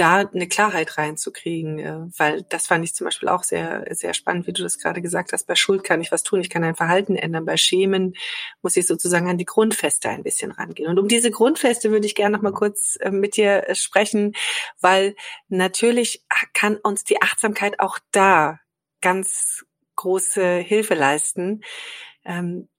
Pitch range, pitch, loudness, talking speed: 170-210 Hz, 190 Hz, -20 LUFS, 175 wpm